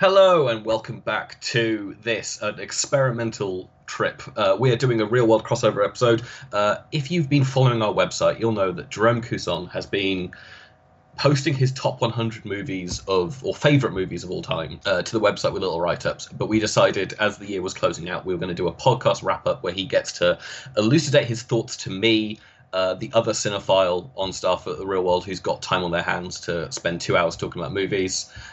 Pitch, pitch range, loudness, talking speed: 110 Hz, 95-130 Hz, -23 LUFS, 210 wpm